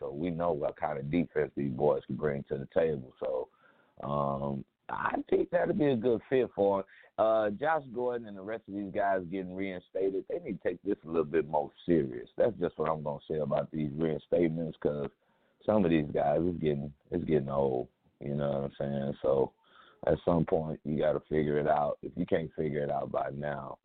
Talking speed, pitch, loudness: 225 wpm, 90 Hz, -32 LUFS